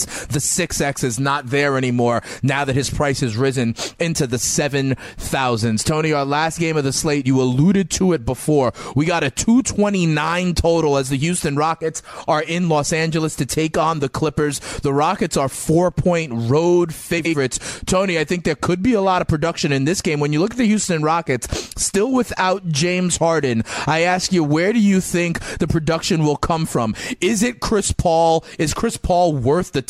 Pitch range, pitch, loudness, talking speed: 140-175 Hz, 160 Hz, -18 LUFS, 195 wpm